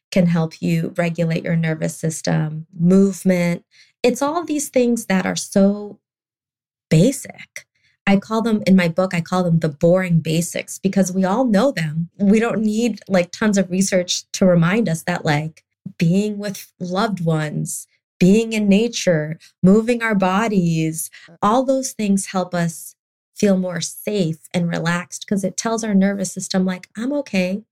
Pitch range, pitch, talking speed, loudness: 170-210 Hz, 185 Hz, 160 wpm, -19 LUFS